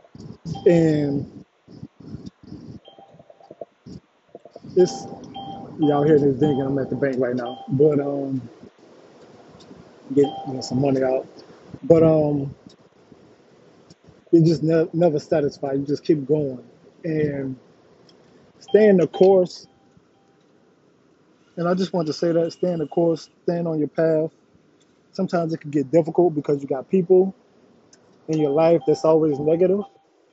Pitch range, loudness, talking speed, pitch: 140-170 Hz, -20 LUFS, 130 wpm, 155 Hz